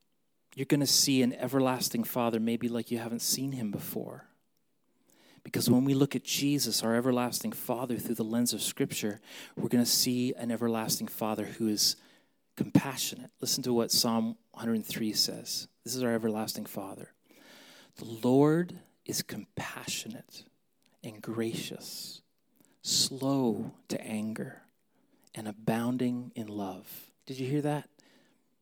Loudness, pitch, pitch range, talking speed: -30 LUFS, 120 Hz, 115-135 Hz, 140 wpm